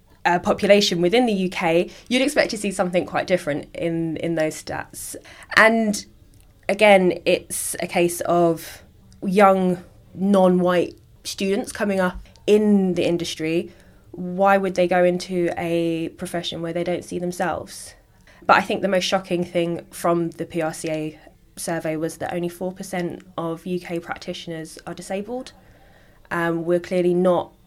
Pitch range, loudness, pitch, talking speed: 165-190 Hz, -21 LUFS, 175 Hz, 145 wpm